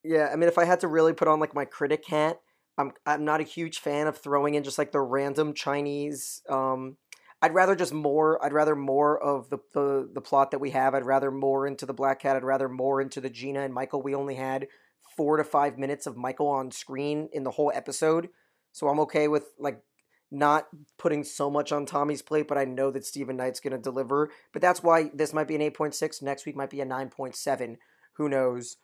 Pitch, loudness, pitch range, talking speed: 145 Hz, -27 LUFS, 135-155 Hz, 235 wpm